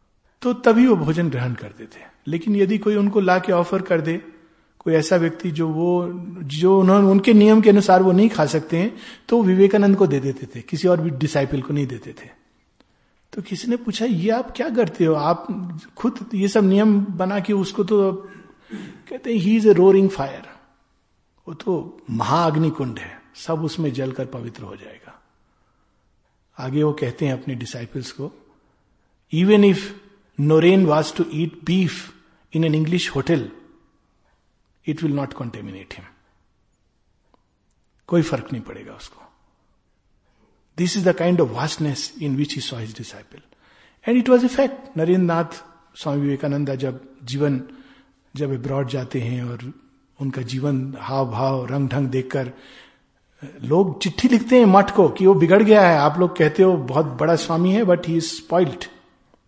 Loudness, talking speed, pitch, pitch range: -19 LUFS, 165 wpm, 165 Hz, 140-195 Hz